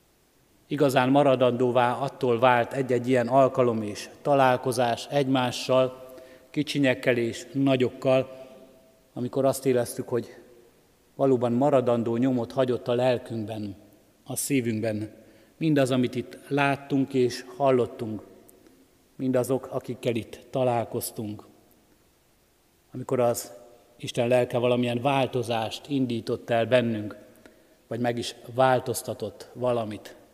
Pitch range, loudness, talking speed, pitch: 120-130 Hz, -25 LUFS, 95 wpm, 125 Hz